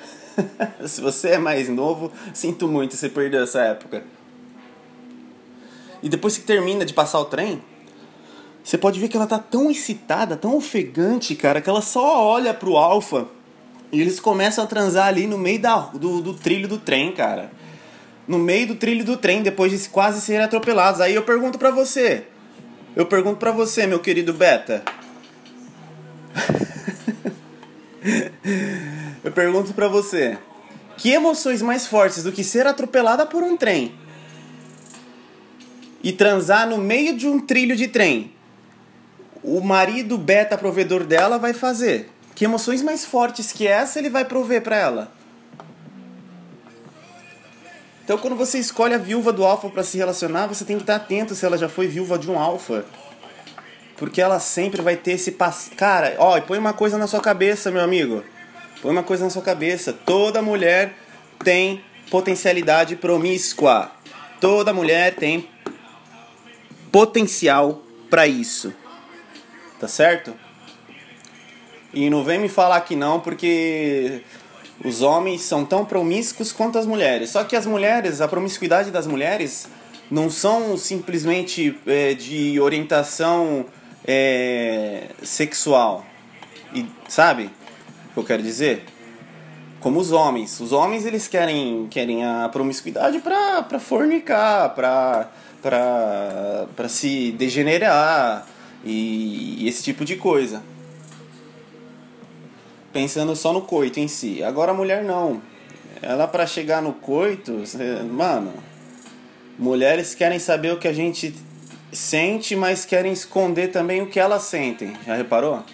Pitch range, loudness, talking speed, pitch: 155-215 Hz, -20 LUFS, 140 wpm, 185 Hz